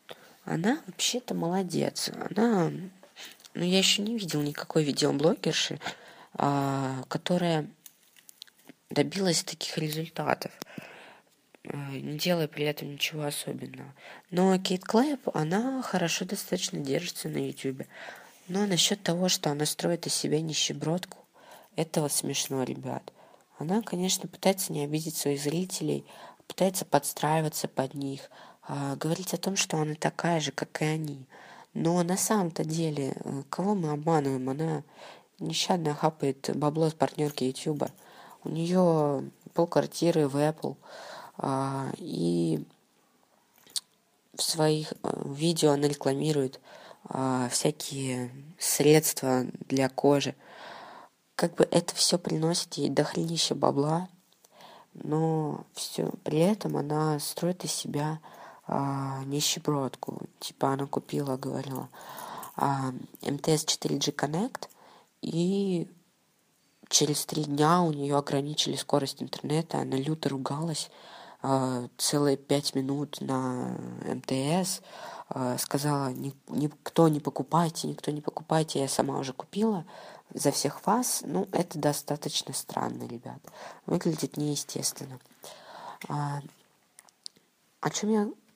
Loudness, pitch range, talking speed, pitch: -29 LUFS, 140-175 Hz, 110 wpm, 150 Hz